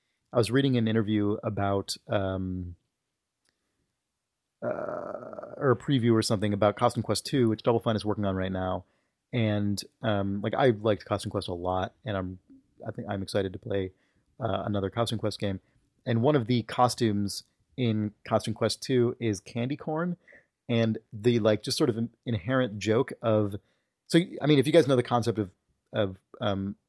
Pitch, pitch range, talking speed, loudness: 110 Hz, 100-120 Hz, 180 wpm, -28 LUFS